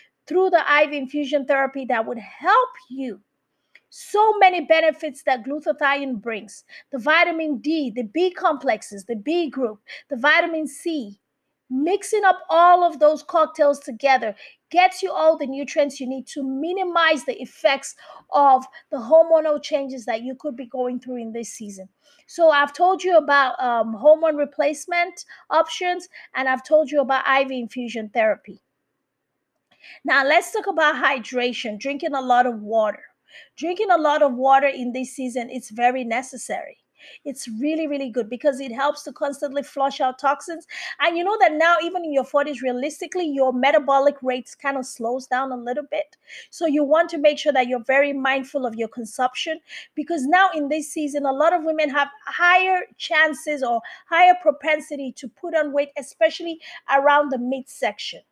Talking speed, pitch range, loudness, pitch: 170 wpm, 260-320 Hz, -21 LUFS, 285 Hz